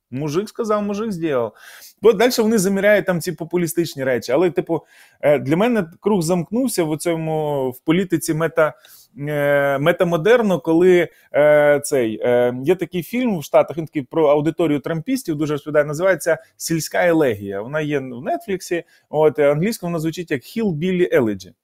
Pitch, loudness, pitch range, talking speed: 165 Hz, -19 LUFS, 150-185 Hz, 145 wpm